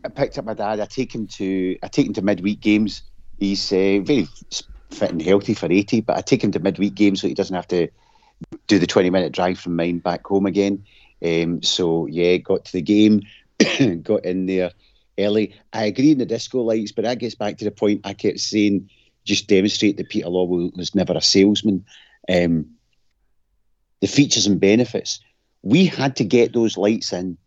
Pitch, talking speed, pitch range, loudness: 100 Hz, 200 wpm, 90-110 Hz, -20 LUFS